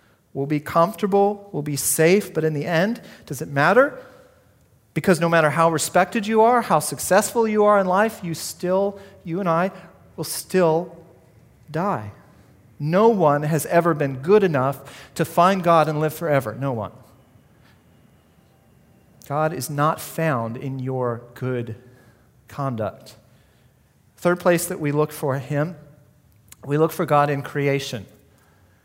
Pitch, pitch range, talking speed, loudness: 150 Hz, 135-175 Hz, 145 wpm, -21 LUFS